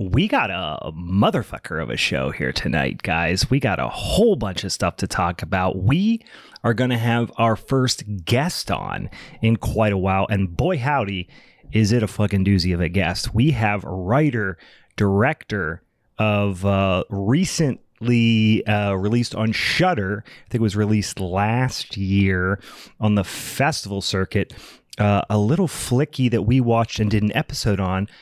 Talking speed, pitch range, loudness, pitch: 170 wpm, 95-125 Hz, -21 LUFS, 105 Hz